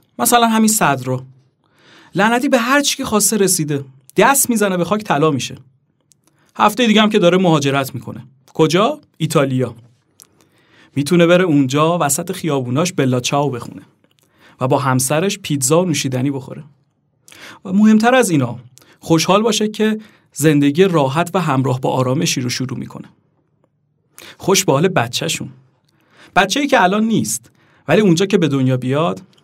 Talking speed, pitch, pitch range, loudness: 145 wpm, 155 Hz, 135-190 Hz, -15 LUFS